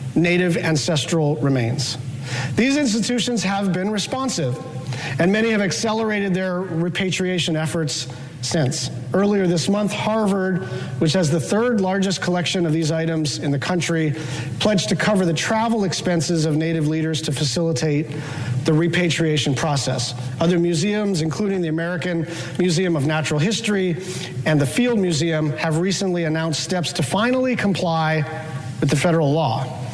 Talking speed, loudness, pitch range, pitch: 140 wpm, -20 LUFS, 150-190 Hz, 165 Hz